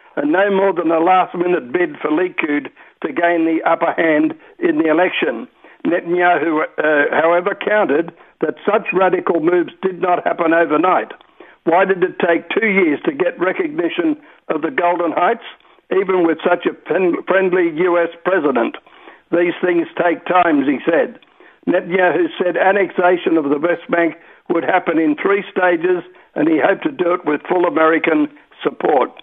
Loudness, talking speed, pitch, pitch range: -16 LUFS, 160 wpm, 180 Hz, 170-210 Hz